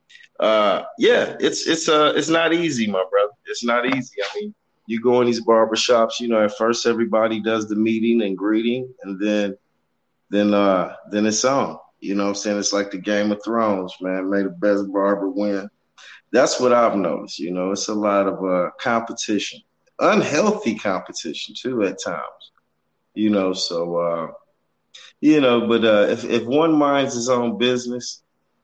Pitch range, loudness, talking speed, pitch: 100-125 Hz, -20 LUFS, 180 wpm, 110 Hz